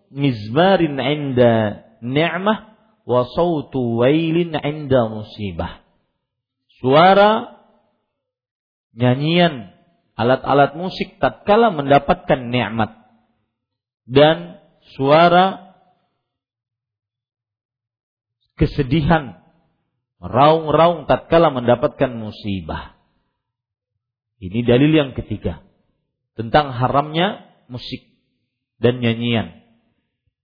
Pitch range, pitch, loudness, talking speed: 115-165 Hz, 130 Hz, -17 LUFS, 55 wpm